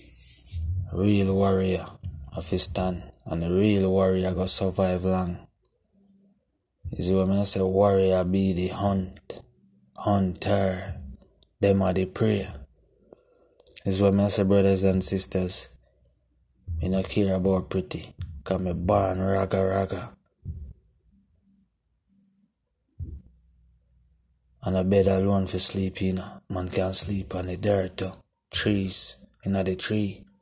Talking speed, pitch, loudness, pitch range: 120 wpm, 95 Hz, -24 LUFS, 90-100 Hz